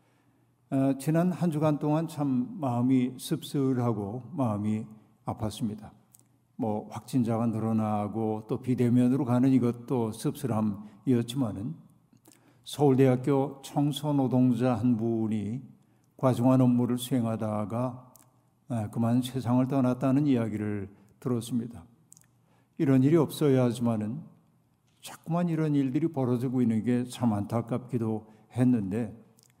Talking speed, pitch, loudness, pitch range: 260 characters per minute, 125 Hz, -28 LUFS, 115-135 Hz